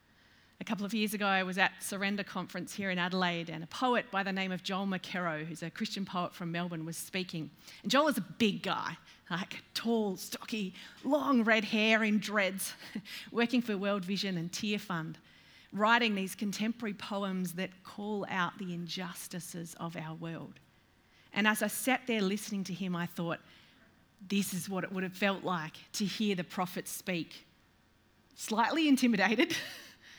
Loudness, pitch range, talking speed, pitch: -33 LUFS, 175-215 Hz, 175 wpm, 195 Hz